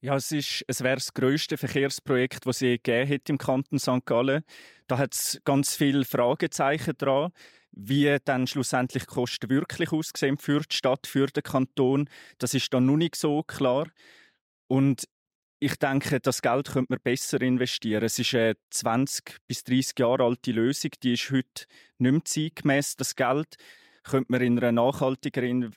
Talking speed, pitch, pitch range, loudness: 170 wpm, 135 Hz, 125-140 Hz, -26 LUFS